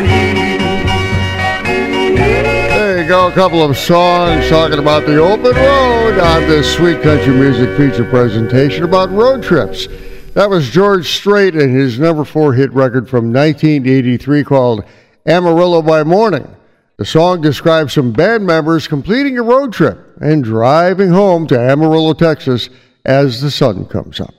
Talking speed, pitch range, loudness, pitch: 145 wpm, 125-175 Hz, -11 LUFS, 150 Hz